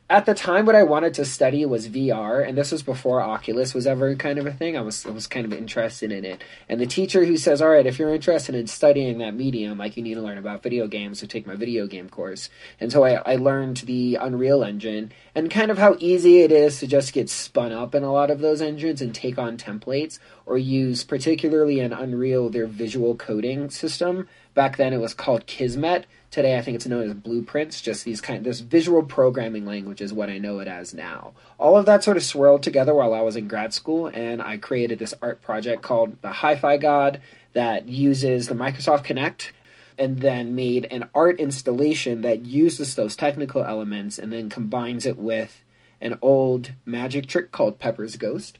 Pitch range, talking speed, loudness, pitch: 115-150 Hz, 215 wpm, -22 LUFS, 130 Hz